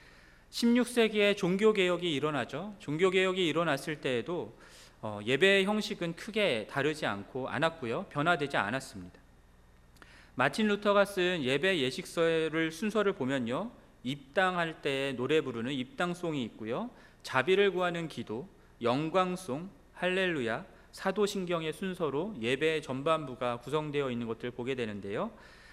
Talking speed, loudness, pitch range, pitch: 295 characters per minute, -31 LUFS, 130-190 Hz, 160 Hz